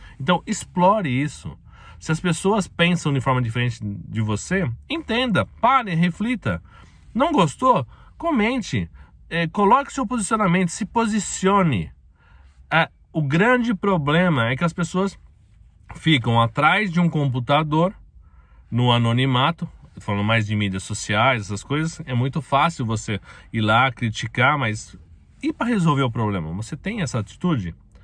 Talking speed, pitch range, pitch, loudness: 135 wpm, 110-185 Hz, 145 Hz, -21 LUFS